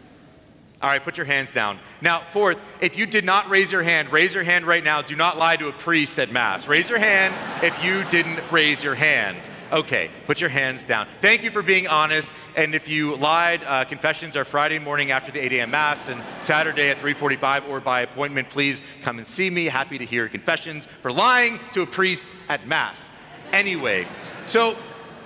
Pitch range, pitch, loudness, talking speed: 140-175 Hz, 155 Hz, -20 LUFS, 205 wpm